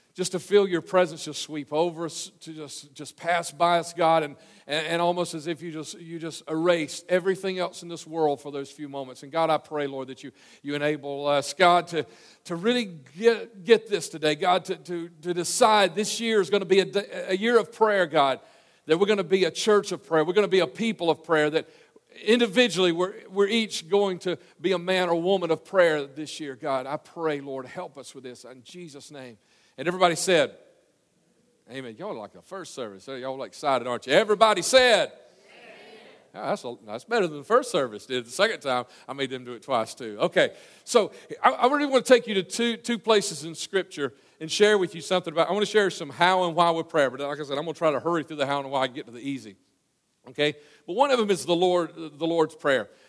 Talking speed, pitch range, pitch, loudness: 240 wpm, 150-190 Hz, 170 Hz, -25 LUFS